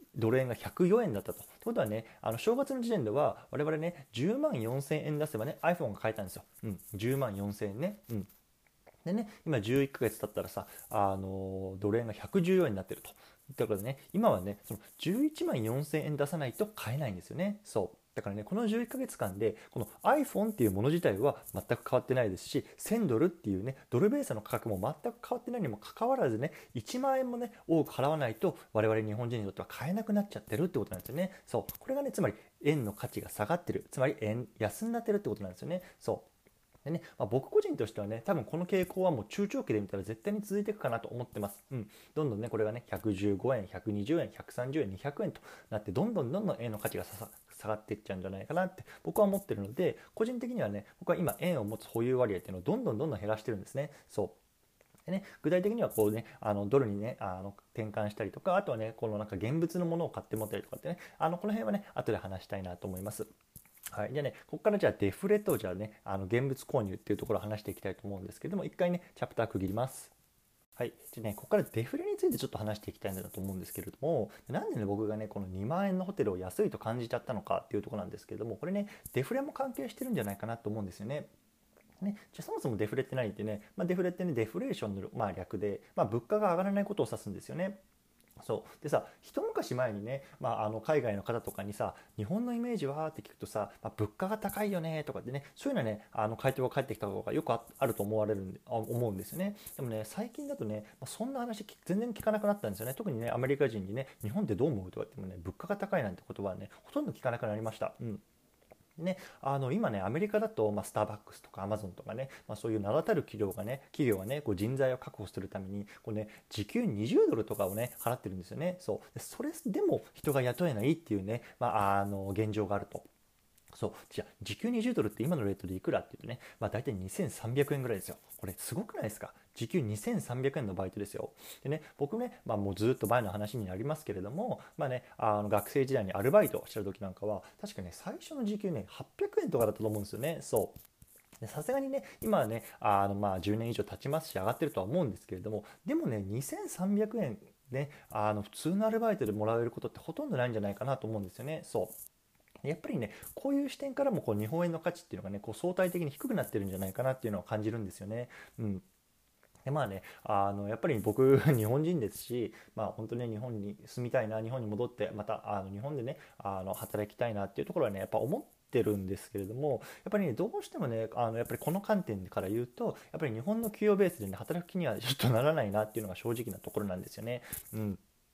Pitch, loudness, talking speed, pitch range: 120 Hz, -35 LUFS, 475 characters per minute, 105-175 Hz